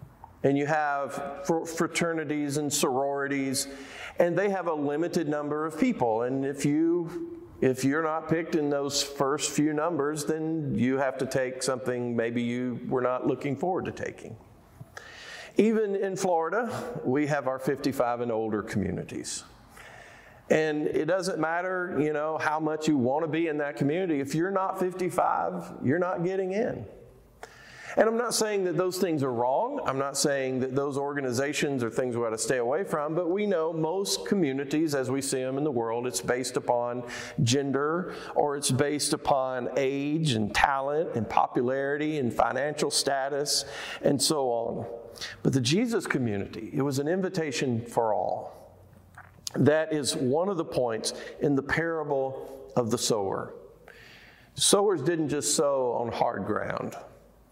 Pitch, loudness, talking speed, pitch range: 145 Hz, -28 LUFS, 165 wpm, 130-165 Hz